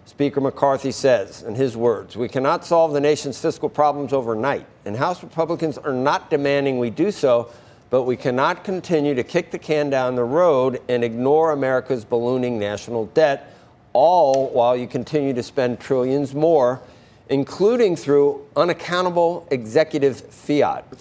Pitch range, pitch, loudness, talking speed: 125-150 Hz, 140 Hz, -20 LUFS, 150 wpm